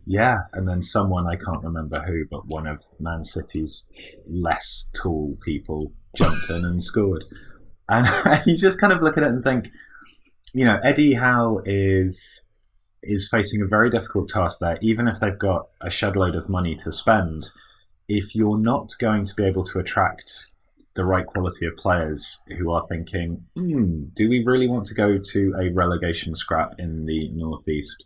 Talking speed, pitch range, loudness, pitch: 180 wpm, 85-110 Hz, -22 LUFS, 95 Hz